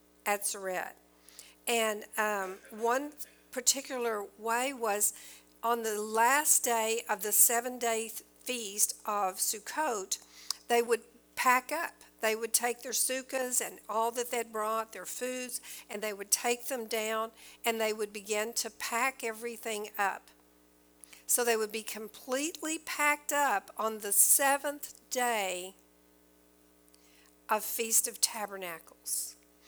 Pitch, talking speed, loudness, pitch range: 220 Hz, 130 wpm, -31 LUFS, 195-245 Hz